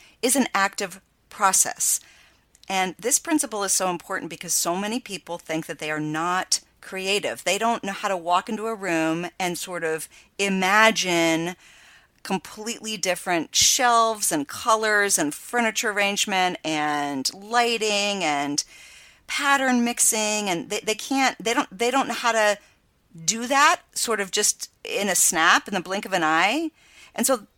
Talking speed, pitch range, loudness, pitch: 160 wpm, 180-230 Hz, -22 LUFS, 200 Hz